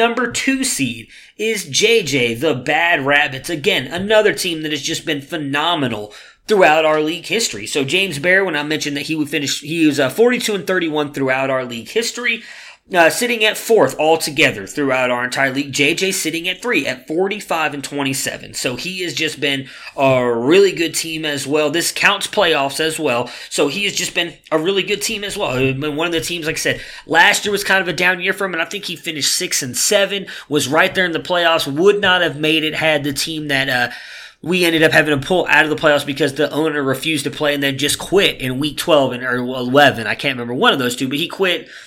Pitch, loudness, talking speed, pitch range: 155 Hz, -16 LUFS, 230 wpm, 140-185 Hz